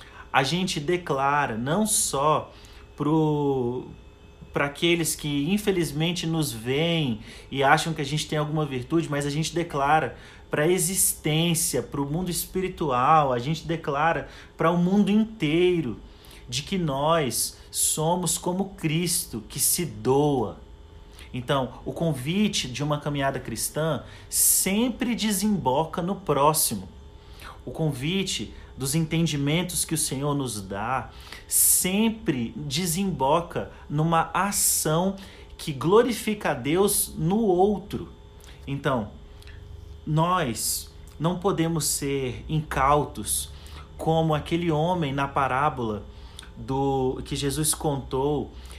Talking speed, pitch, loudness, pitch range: 115 wpm, 150 Hz, -24 LUFS, 125-170 Hz